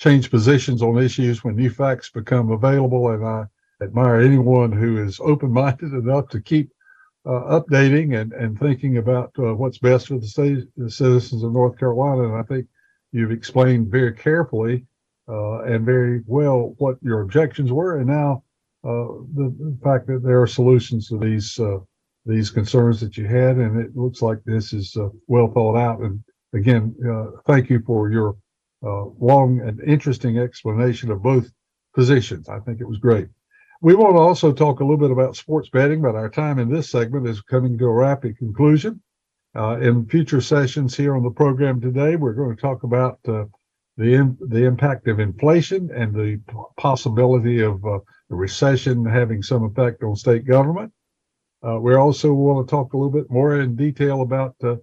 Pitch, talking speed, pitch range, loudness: 125 Hz, 185 wpm, 115-140 Hz, -19 LUFS